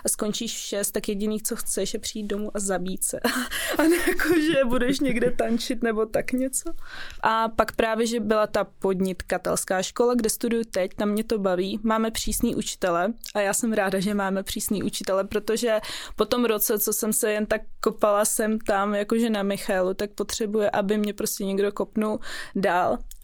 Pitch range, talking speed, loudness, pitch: 205-230 Hz, 185 wpm, -25 LUFS, 220 Hz